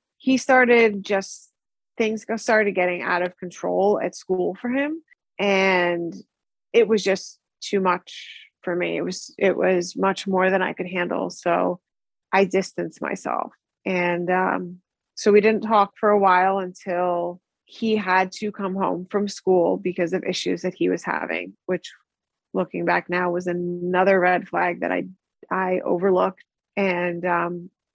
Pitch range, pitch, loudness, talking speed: 180-205 Hz, 185 Hz, -22 LUFS, 155 wpm